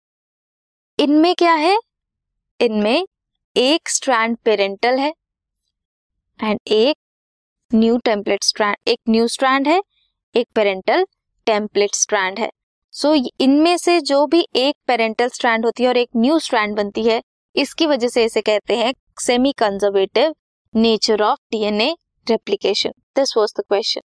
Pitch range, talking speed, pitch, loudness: 215-295 Hz, 125 wpm, 235 Hz, -18 LUFS